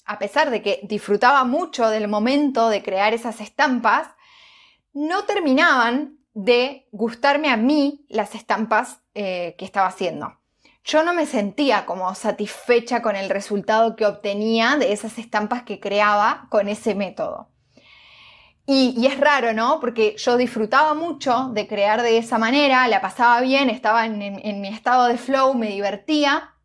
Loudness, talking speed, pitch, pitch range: -20 LUFS, 160 wpm, 230 Hz, 210-275 Hz